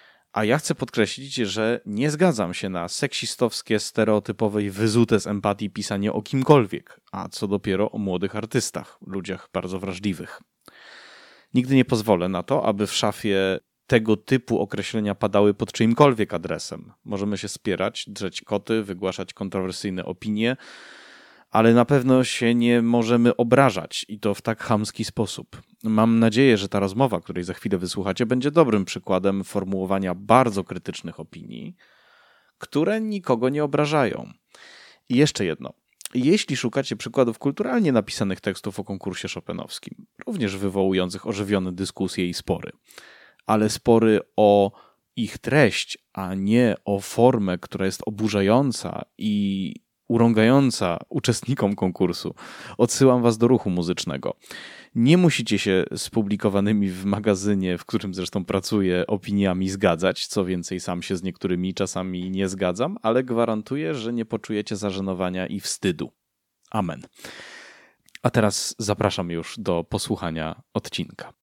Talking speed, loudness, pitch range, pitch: 135 wpm, -23 LUFS, 95-120 Hz, 105 Hz